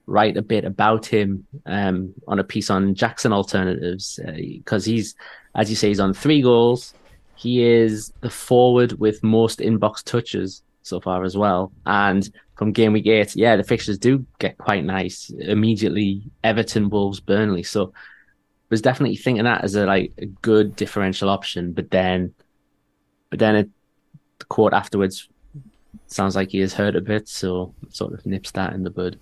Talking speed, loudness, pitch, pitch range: 175 wpm, -20 LUFS, 105 Hz, 95-115 Hz